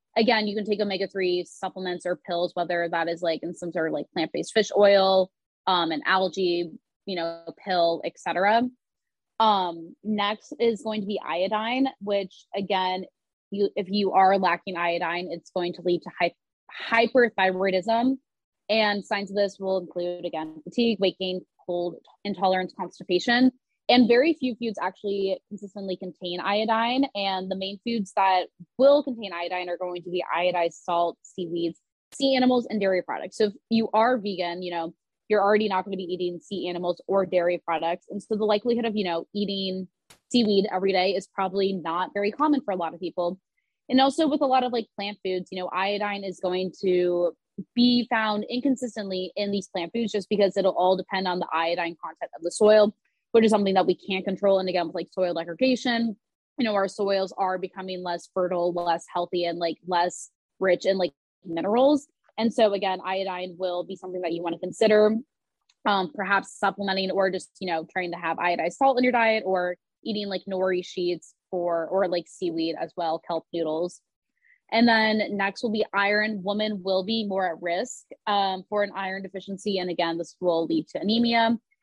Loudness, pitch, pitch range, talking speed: -25 LUFS, 190 Hz, 175-210 Hz, 190 wpm